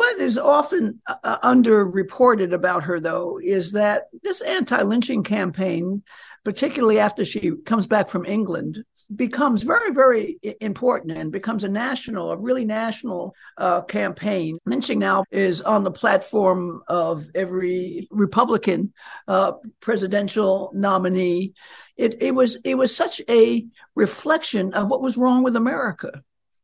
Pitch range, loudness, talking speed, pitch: 190-250 Hz, -21 LUFS, 135 wpm, 215 Hz